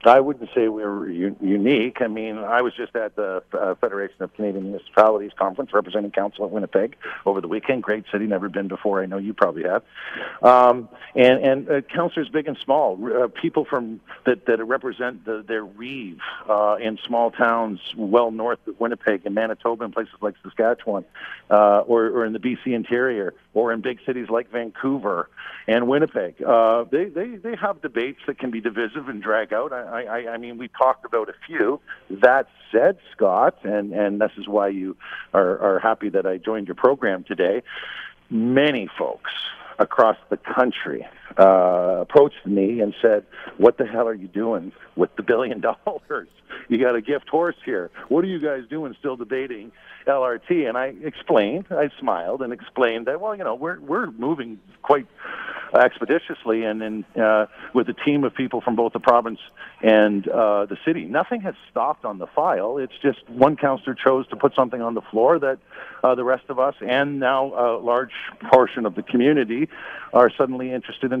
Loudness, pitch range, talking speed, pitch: -21 LUFS, 105-130 Hz, 190 wpm, 115 Hz